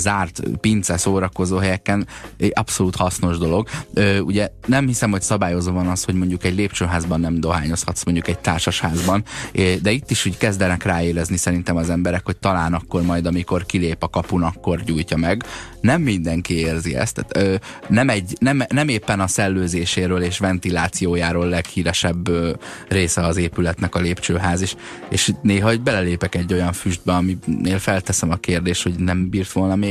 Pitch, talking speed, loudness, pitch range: 90 Hz, 170 wpm, -20 LUFS, 85-100 Hz